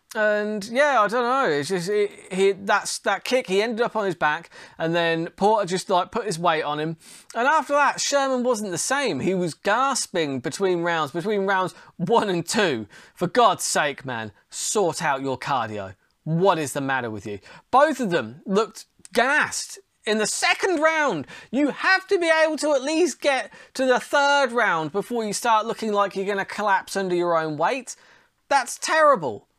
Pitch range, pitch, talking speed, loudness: 170-260 Hz, 205 Hz, 195 wpm, -22 LUFS